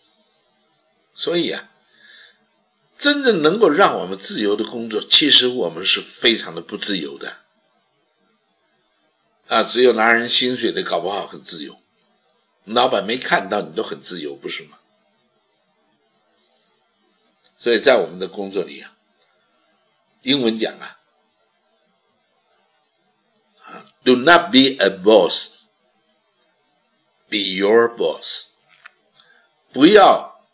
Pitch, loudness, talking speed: 125 Hz, -16 LUFS, 185 characters per minute